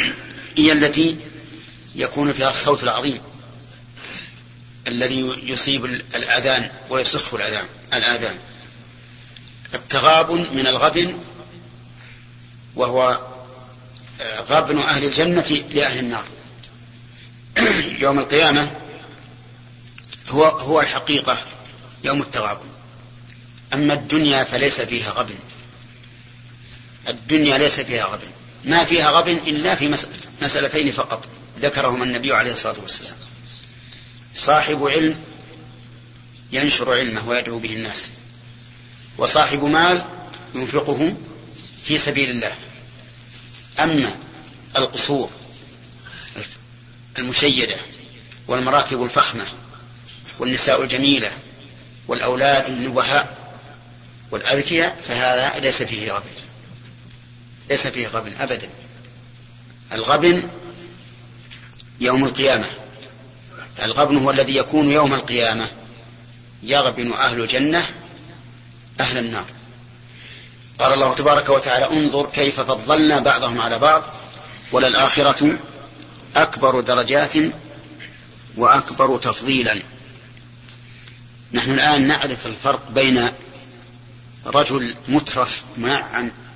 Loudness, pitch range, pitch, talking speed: -18 LUFS, 120-140 Hz, 125 Hz, 80 wpm